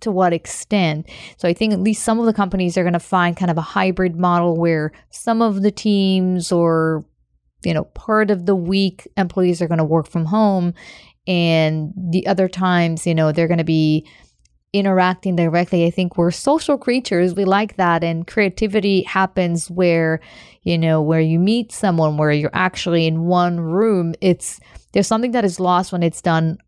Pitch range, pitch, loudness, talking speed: 165-195 Hz, 180 Hz, -18 LUFS, 190 wpm